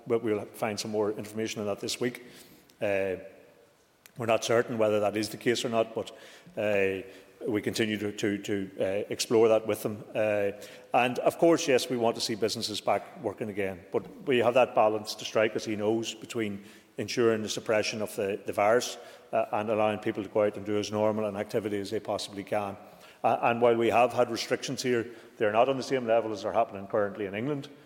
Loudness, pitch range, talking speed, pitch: -29 LUFS, 105-115 Hz, 215 wpm, 110 Hz